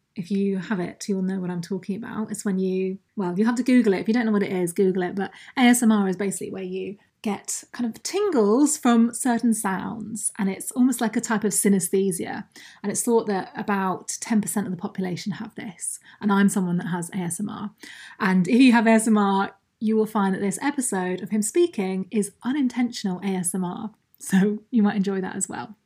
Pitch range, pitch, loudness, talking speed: 190-225 Hz, 205 Hz, -23 LUFS, 210 wpm